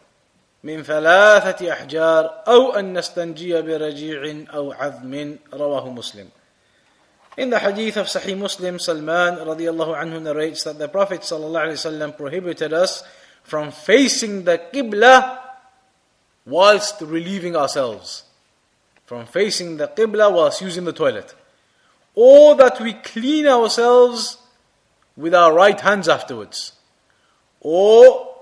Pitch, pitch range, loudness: 180 Hz, 155-230 Hz, -16 LUFS